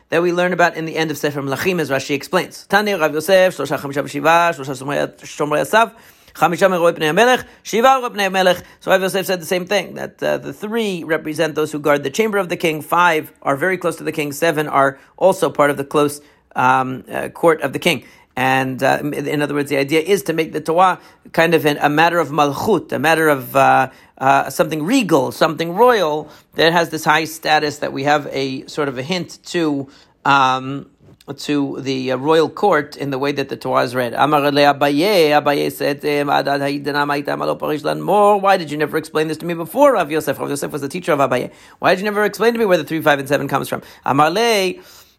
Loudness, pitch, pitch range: -17 LUFS, 155 Hz, 145-175 Hz